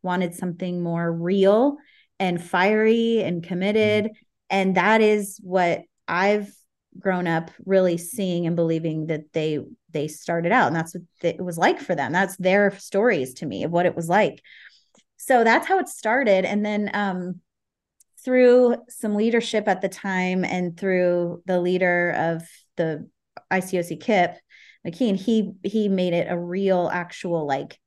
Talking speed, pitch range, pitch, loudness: 155 wpm, 175-210 Hz, 185 Hz, -22 LUFS